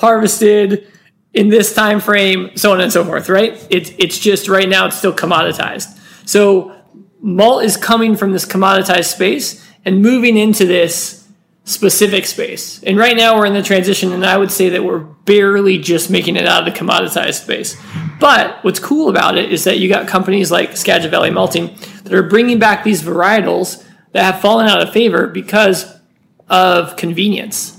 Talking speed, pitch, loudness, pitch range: 180 wpm, 195 Hz, -12 LUFS, 185-210 Hz